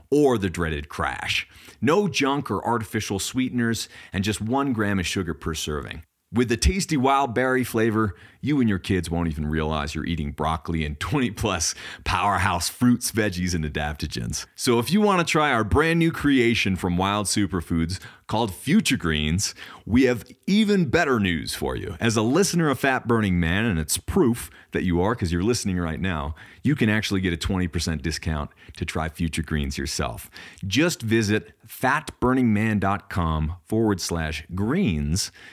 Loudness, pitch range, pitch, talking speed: -24 LUFS, 85-120 Hz, 100 Hz, 170 wpm